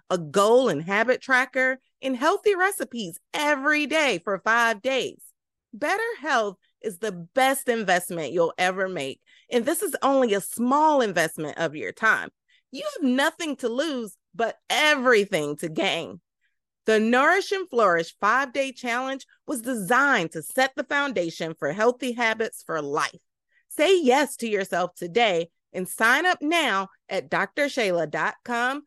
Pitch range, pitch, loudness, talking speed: 190-285 Hz, 245 Hz, -24 LUFS, 145 wpm